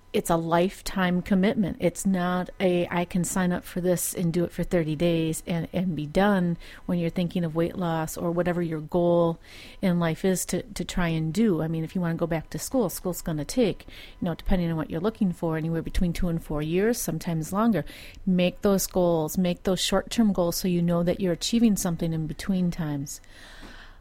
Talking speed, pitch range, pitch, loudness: 220 wpm, 165-185 Hz, 175 Hz, -26 LUFS